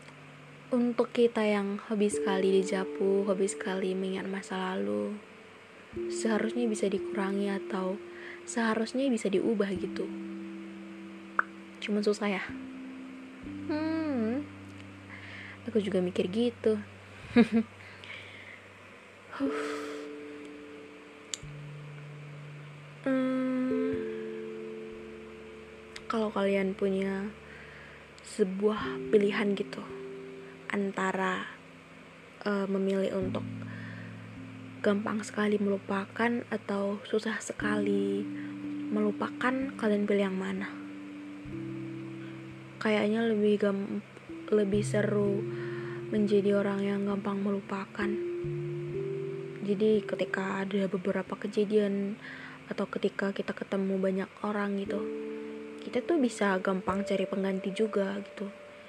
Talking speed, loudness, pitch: 80 wpm, -31 LUFS, 190 Hz